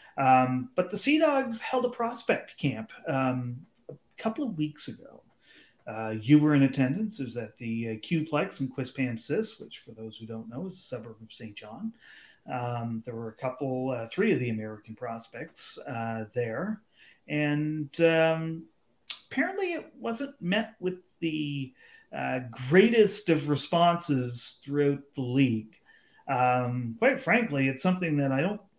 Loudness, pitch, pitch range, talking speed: -28 LUFS, 140 Hz, 125-180 Hz, 155 wpm